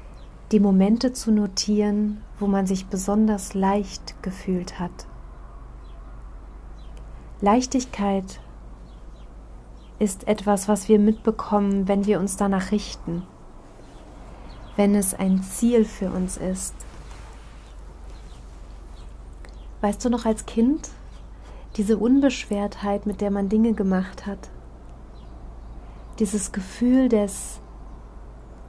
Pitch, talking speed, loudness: 195 Hz, 95 wpm, -23 LUFS